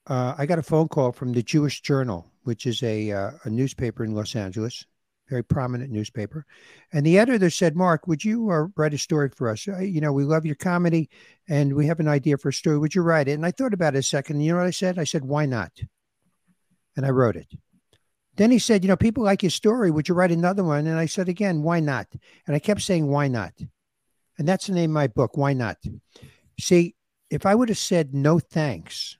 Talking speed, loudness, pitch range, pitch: 240 wpm, -23 LUFS, 130-175 Hz, 150 Hz